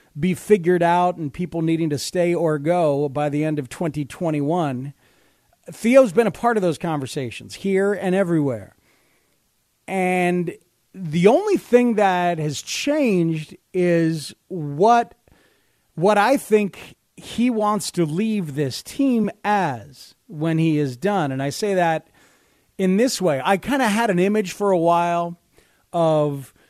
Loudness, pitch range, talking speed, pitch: -20 LUFS, 155-205 Hz, 145 wpm, 175 Hz